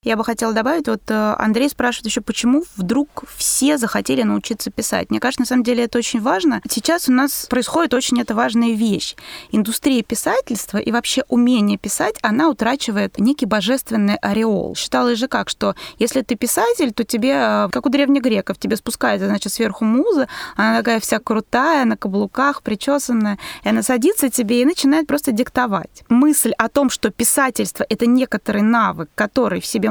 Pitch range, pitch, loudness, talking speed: 220-265 Hz, 240 Hz, -18 LUFS, 170 wpm